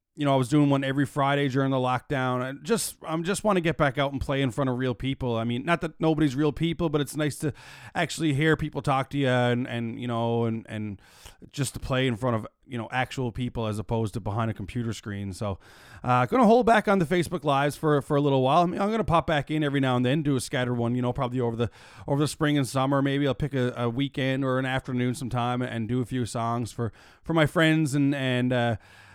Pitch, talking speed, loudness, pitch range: 130 Hz, 270 wpm, -26 LUFS, 120-150 Hz